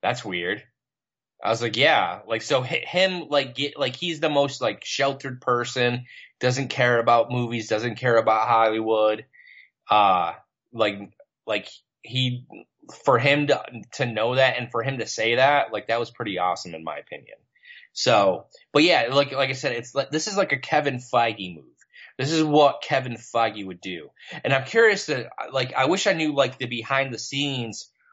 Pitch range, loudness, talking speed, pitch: 115-145 Hz, -23 LUFS, 185 wpm, 130 Hz